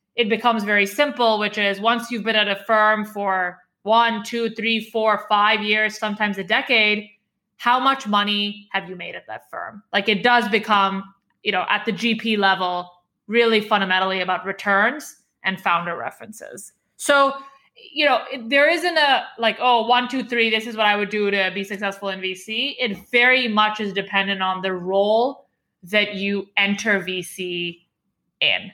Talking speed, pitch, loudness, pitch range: 175 wpm, 210 Hz, -20 LUFS, 195-235 Hz